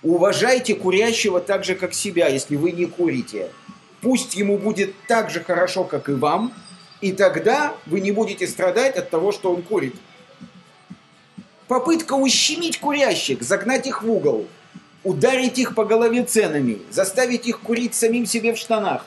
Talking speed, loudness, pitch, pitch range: 155 wpm, -20 LUFS, 220 Hz, 185-245 Hz